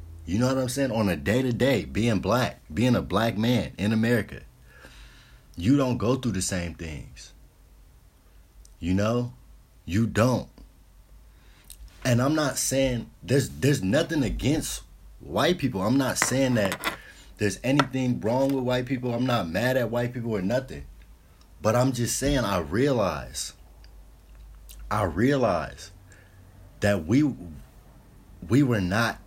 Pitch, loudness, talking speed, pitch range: 110 Hz, -25 LUFS, 145 wpm, 90-125 Hz